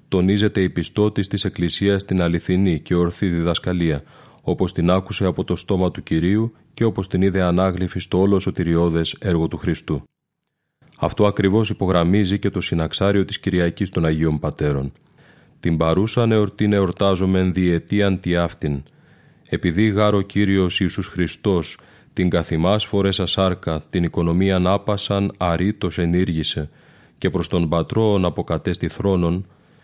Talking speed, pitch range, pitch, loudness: 135 wpm, 85-100 Hz, 95 Hz, -20 LUFS